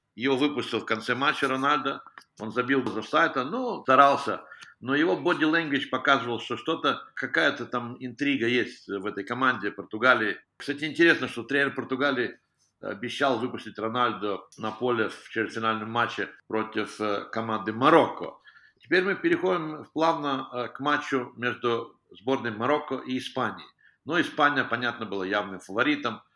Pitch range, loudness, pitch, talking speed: 110-140 Hz, -26 LUFS, 125 Hz, 135 wpm